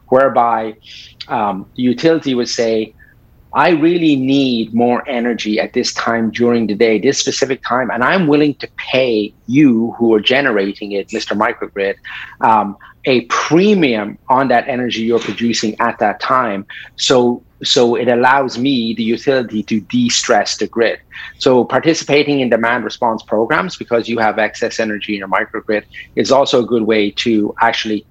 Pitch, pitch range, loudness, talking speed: 115 Hz, 110-130 Hz, -15 LUFS, 160 wpm